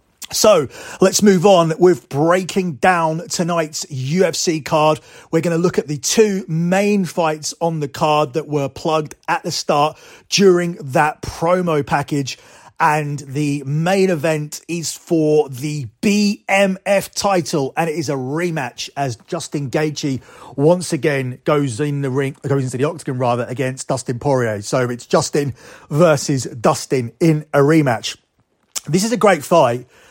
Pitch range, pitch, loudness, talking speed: 140-175 Hz, 155 Hz, -17 LUFS, 150 wpm